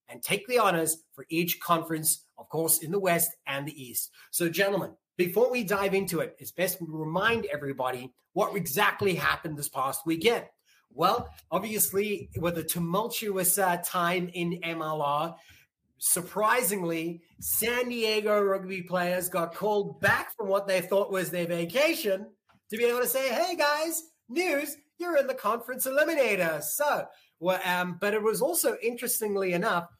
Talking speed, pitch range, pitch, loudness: 160 wpm, 170-220 Hz, 190 Hz, -28 LUFS